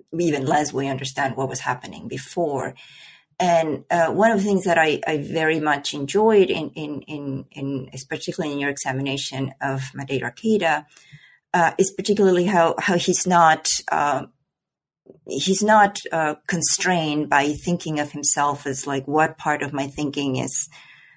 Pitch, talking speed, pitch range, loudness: 150 Hz, 155 wpm, 140-175 Hz, -21 LUFS